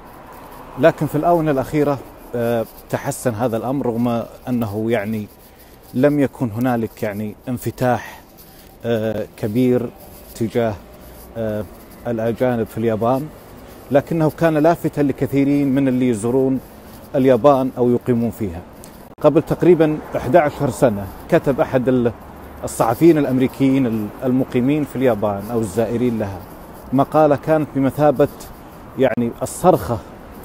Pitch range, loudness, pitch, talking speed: 115-140 Hz, -18 LUFS, 125 Hz, 100 wpm